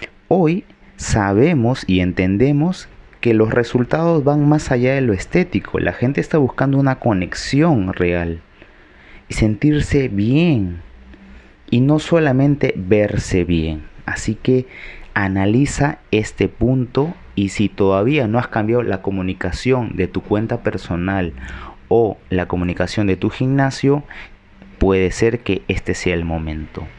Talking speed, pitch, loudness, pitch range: 130 wpm, 105 Hz, -18 LUFS, 95-130 Hz